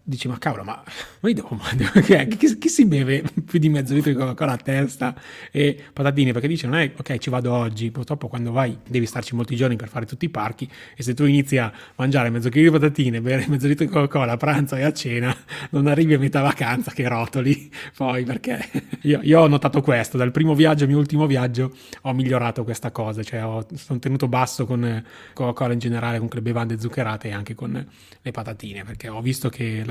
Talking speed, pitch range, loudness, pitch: 225 wpm, 120-145 Hz, -21 LUFS, 130 Hz